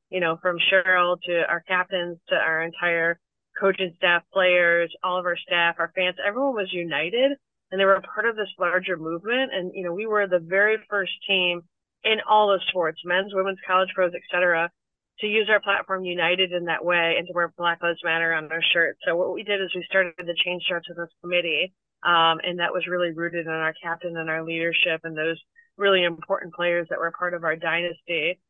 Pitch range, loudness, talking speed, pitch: 170-190 Hz, -23 LUFS, 215 wpm, 175 Hz